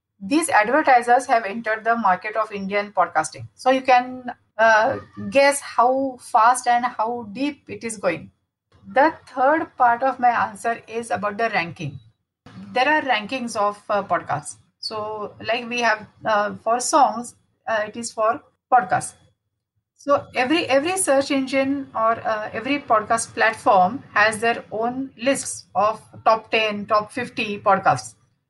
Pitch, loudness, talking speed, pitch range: 230 Hz, -21 LUFS, 145 wpm, 205-255 Hz